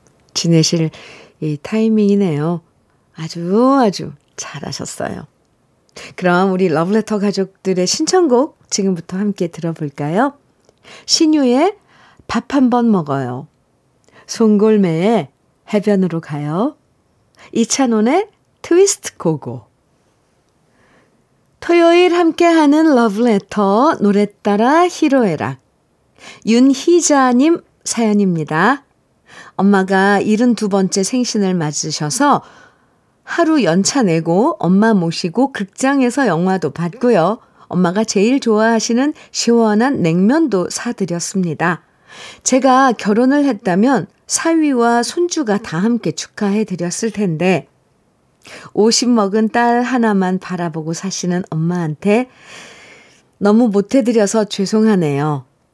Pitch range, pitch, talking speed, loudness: 175-250 Hz, 210 Hz, 230 characters per minute, -15 LUFS